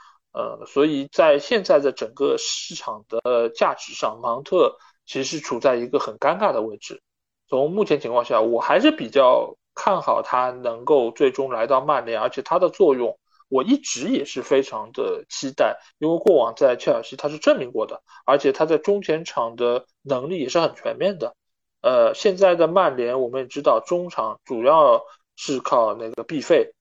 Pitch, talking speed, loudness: 175 Hz, 265 characters per minute, -21 LUFS